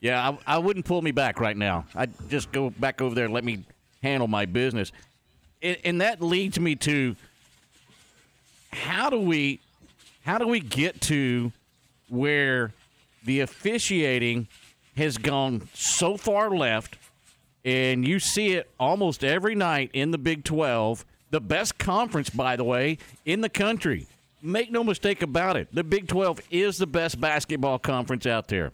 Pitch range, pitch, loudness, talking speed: 125-175 Hz, 145 Hz, -26 LUFS, 165 wpm